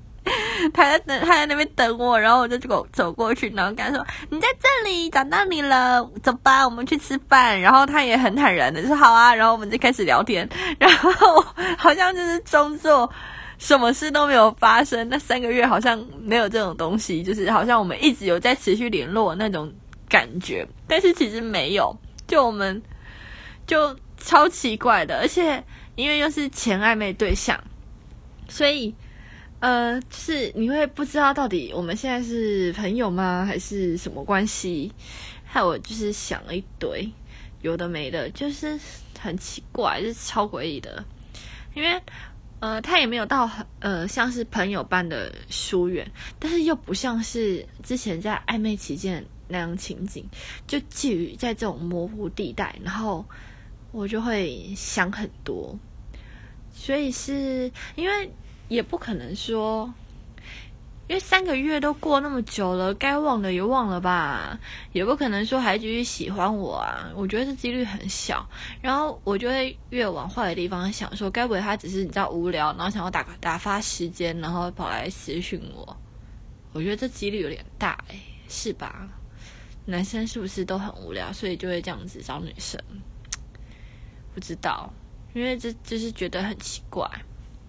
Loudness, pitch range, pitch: -22 LUFS, 190-275 Hz, 230 Hz